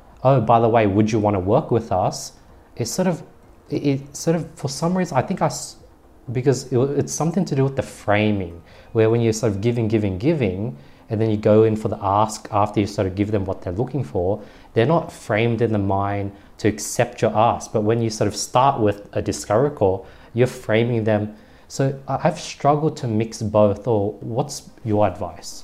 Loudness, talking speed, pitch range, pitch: -21 LUFS, 210 wpm, 105-135 Hz, 110 Hz